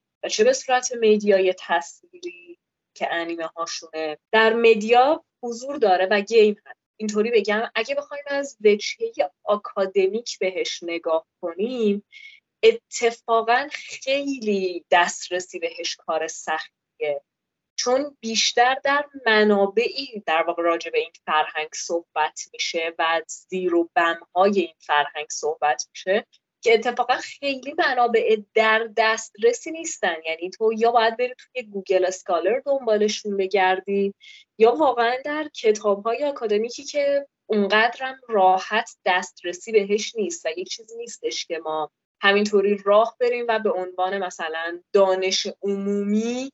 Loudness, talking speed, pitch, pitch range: -22 LUFS, 125 wpm, 215 Hz, 180-255 Hz